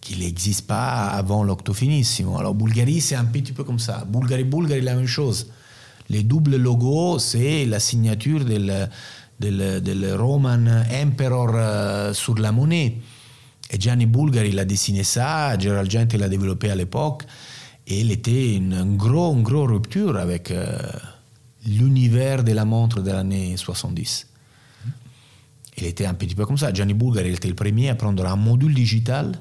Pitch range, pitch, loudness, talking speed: 105-130 Hz, 115 Hz, -21 LUFS, 165 wpm